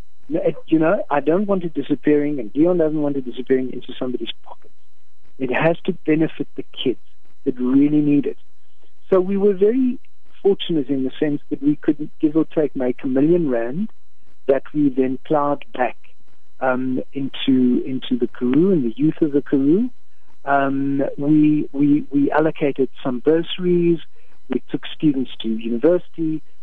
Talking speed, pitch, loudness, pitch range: 165 wpm, 145 Hz, -20 LUFS, 135-165 Hz